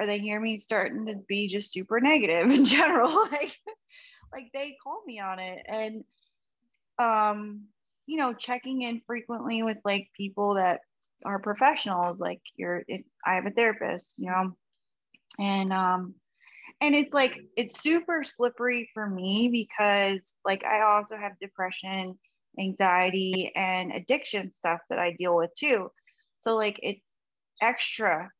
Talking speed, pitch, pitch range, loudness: 150 wpm, 210 Hz, 190-245 Hz, -27 LUFS